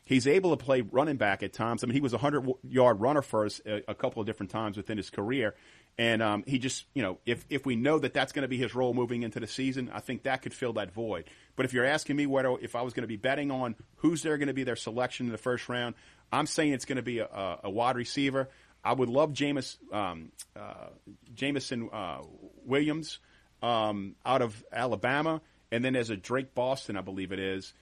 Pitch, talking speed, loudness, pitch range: 125 Hz, 245 wpm, -31 LUFS, 115-135 Hz